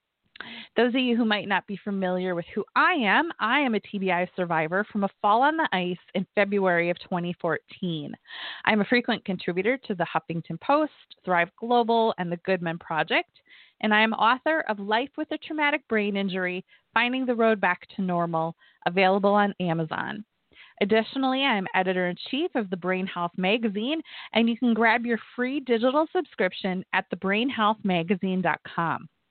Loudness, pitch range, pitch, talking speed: -25 LUFS, 185-240 Hz, 205 Hz, 170 wpm